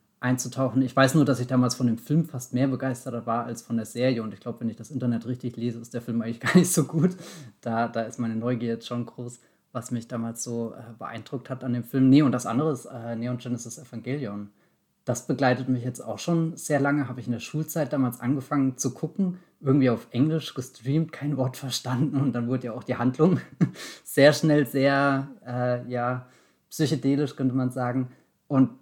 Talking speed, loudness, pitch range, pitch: 215 wpm, -26 LUFS, 120-140 Hz, 125 Hz